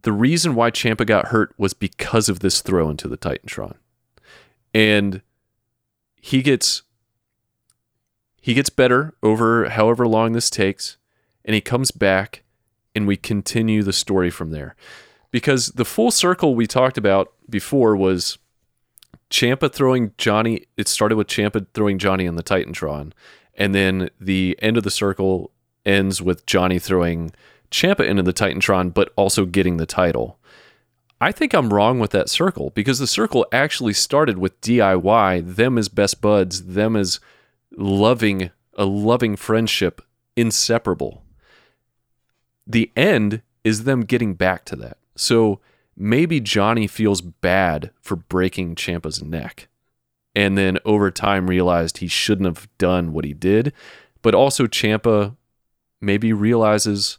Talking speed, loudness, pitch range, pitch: 145 wpm, -19 LUFS, 95-115 Hz, 105 Hz